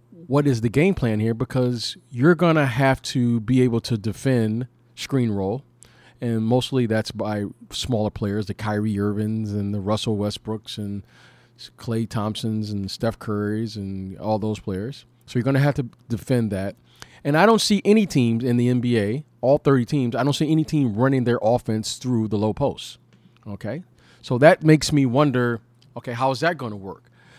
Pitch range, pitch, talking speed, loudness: 110-135 Hz, 120 Hz, 180 wpm, -22 LUFS